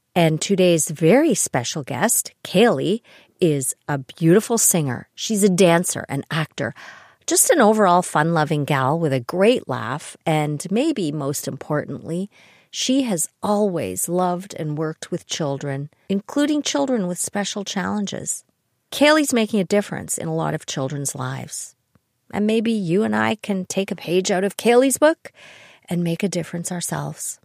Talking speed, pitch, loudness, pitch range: 150 wpm, 175 Hz, -20 LUFS, 150-210 Hz